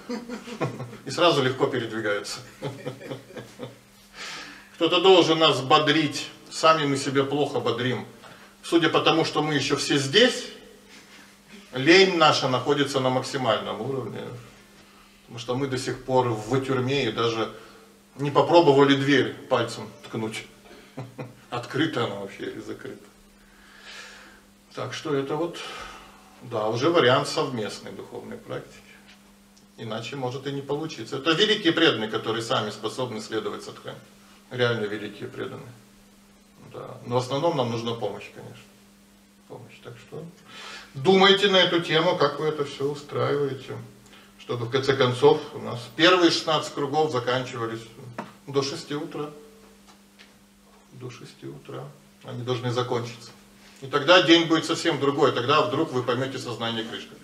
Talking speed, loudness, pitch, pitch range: 130 wpm, -23 LUFS, 135 Hz, 115-155 Hz